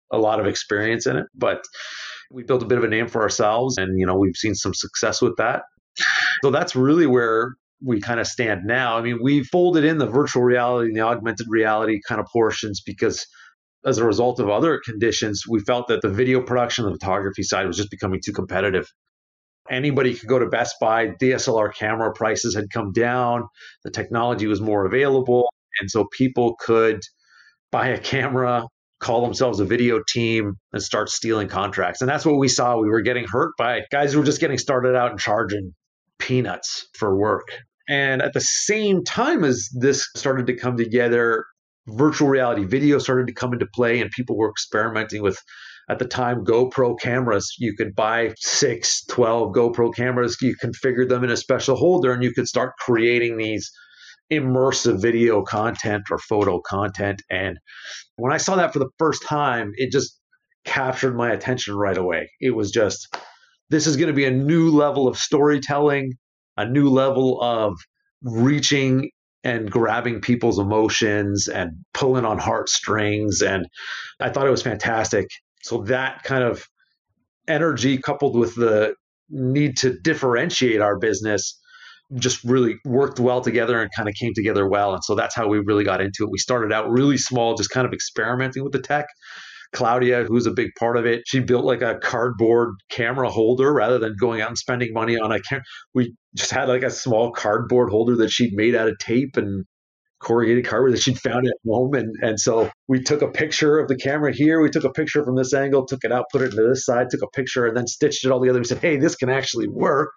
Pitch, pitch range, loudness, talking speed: 120 Hz, 110-130 Hz, -21 LUFS, 195 wpm